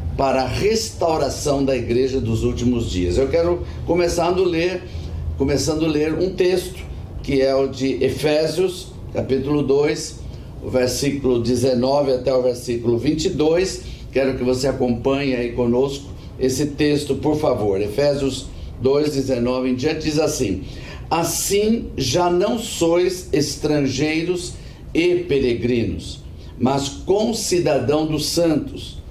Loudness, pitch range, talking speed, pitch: -20 LUFS, 125-155 Hz, 120 wpm, 135 Hz